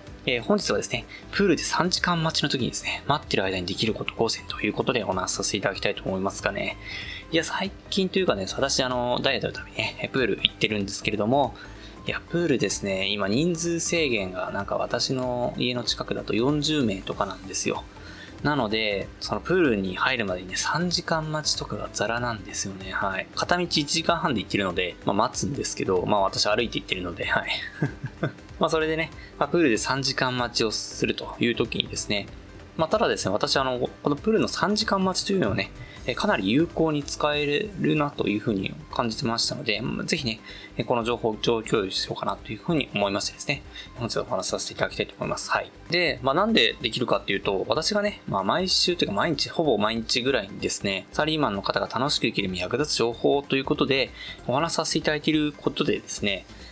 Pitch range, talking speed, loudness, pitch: 105-160 Hz, 435 characters per minute, -25 LUFS, 130 Hz